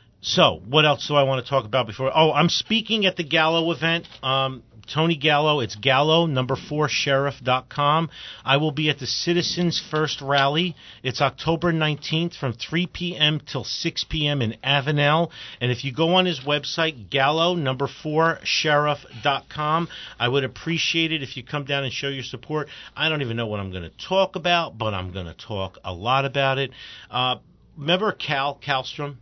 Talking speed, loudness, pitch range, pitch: 190 wpm, -22 LUFS, 130-160 Hz, 145 Hz